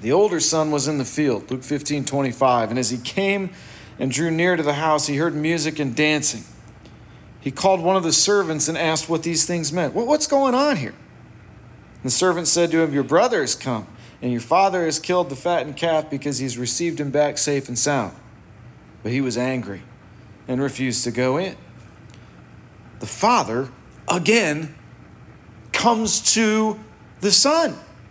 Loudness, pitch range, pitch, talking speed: -19 LUFS, 125-175 Hz, 150 Hz, 180 wpm